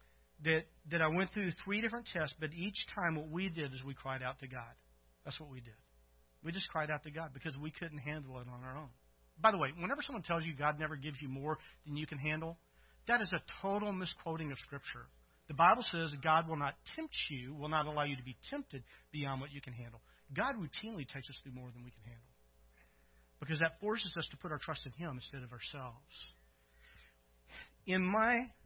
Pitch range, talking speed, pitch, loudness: 125-170 Hz, 220 wpm, 150 Hz, -38 LUFS